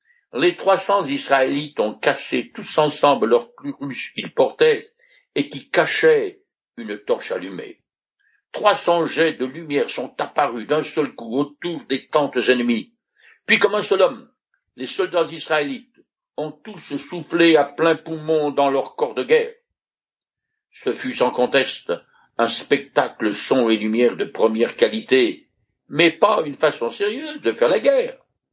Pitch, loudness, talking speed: 170 Hz, -20 LUFS, 150 wpm